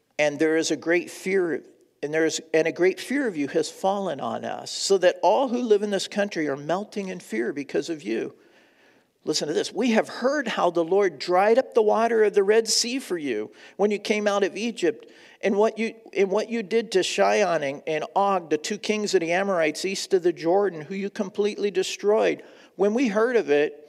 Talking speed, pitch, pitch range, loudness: 225 wpm, 200 Hz, 175-230 Hz, -24 LUFS